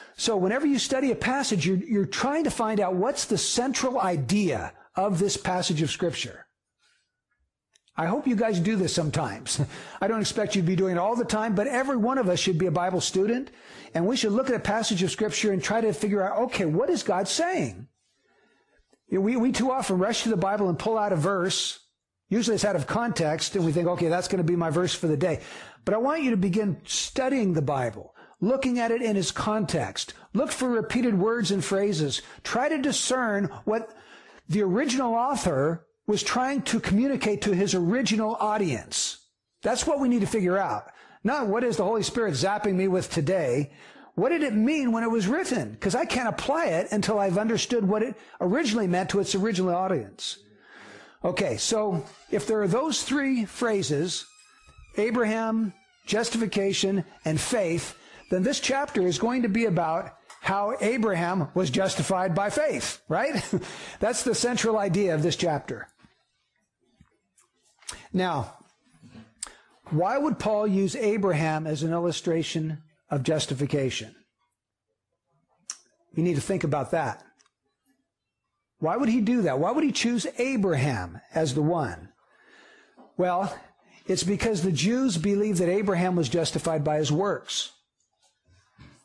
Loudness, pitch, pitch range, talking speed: -26 LUFS, 200 Hz, 175-230 Hz, 170 wpm